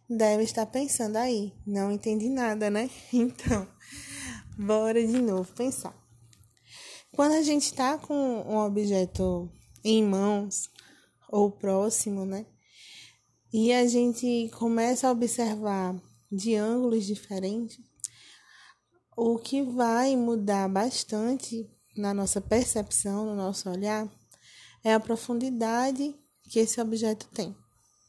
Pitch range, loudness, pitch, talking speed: 205-240 Hz, -28 LUFS, 220 Hz, 110 wpm